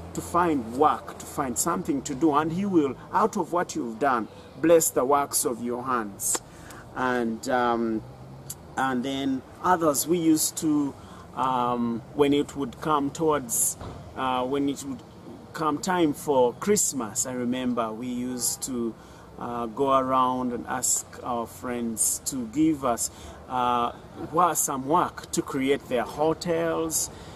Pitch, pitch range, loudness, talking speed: 130 Hz, 120-155 Hz, -26 LUFS, 145 wpm